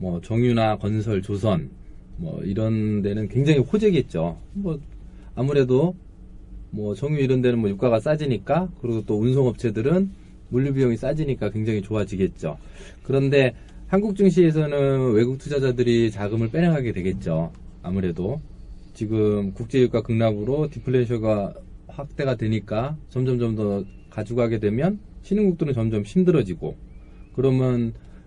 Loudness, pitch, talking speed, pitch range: -23 LUFS, 120 Hz, 310 characters per minute, 105-140 Hz